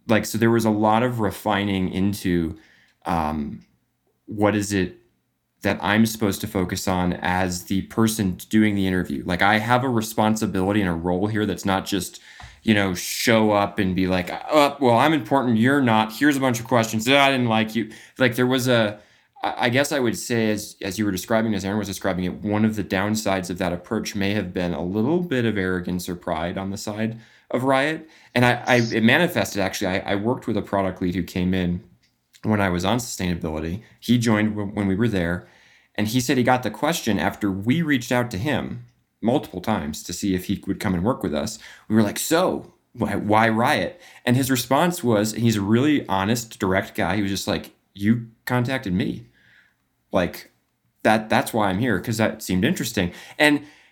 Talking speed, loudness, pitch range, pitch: 215 wpm, -22 LUFS, 95-115 Hz, 105 Hz